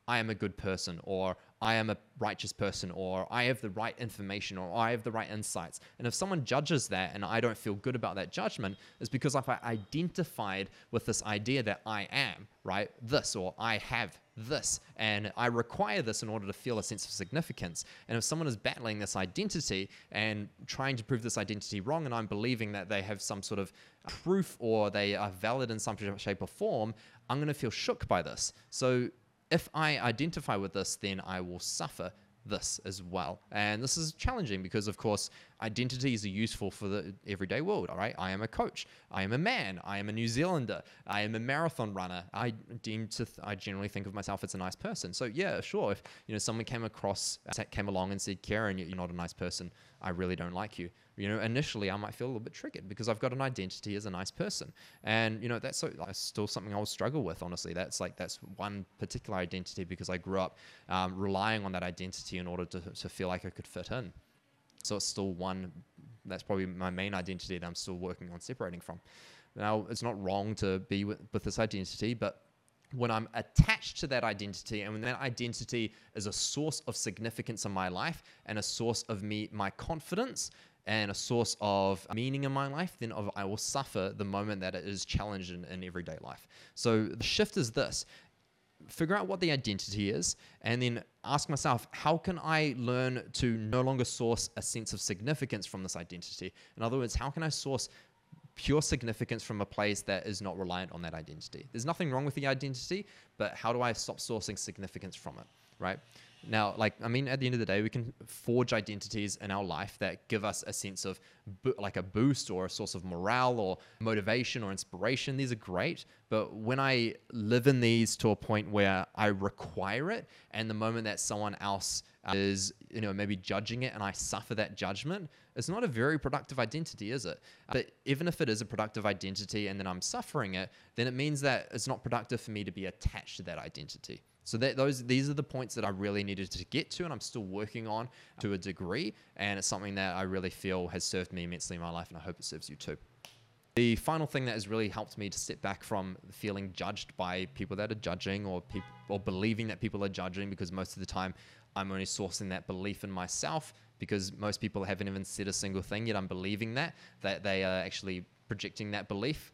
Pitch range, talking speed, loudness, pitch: 95-120 Hz, 225 wpm, -35 LUFS, 105 Hz